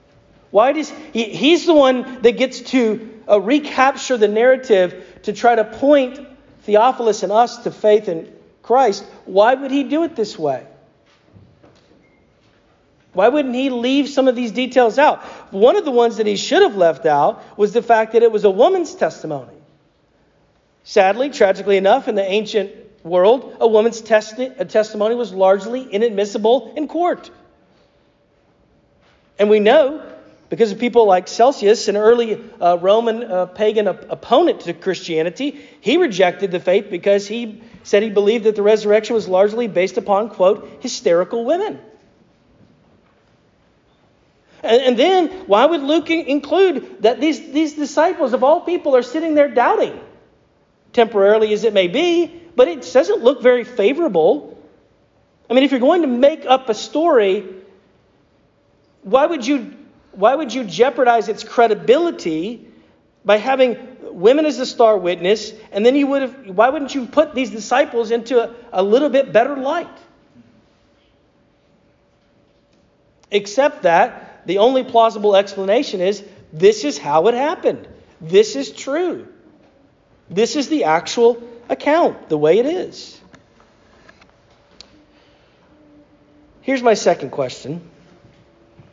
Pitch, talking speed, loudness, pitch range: 235 Hz, 145 wpm, -16 LUFS, 210-280 Hz